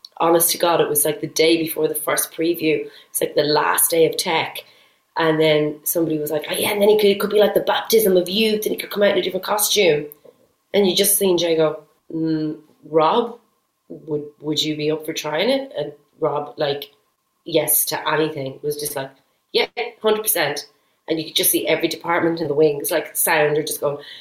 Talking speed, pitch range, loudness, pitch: 225 wpm, 150-200 Hz, -19 LUFS, 160 Hz